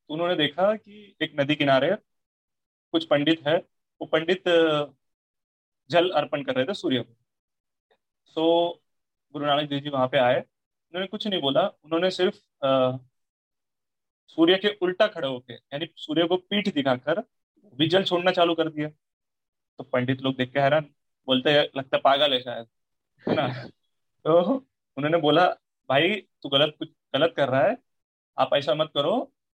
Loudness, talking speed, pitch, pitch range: -24 LUFS, 160 wpm, 150 Hz, 130-175 Hz